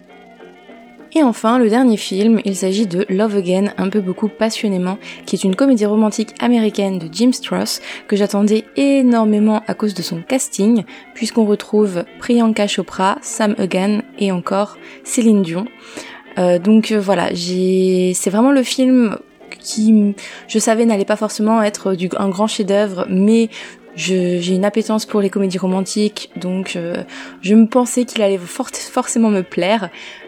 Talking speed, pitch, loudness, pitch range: 160 wpm, 210 Hz, -16 LUFS, 190-225 Hz